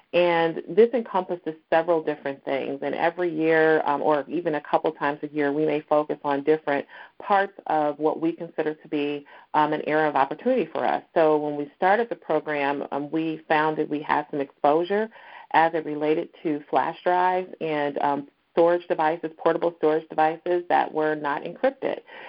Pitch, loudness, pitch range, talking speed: 155 Hz, -24 LUFS, 150-170 Hz, 180 wpm